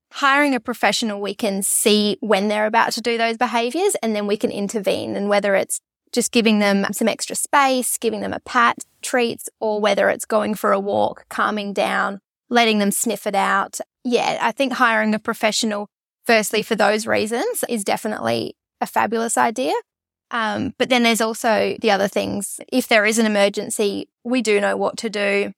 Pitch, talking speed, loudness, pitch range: 220 Hz, 190 wpm, -19 LUFS, 205-235 Hz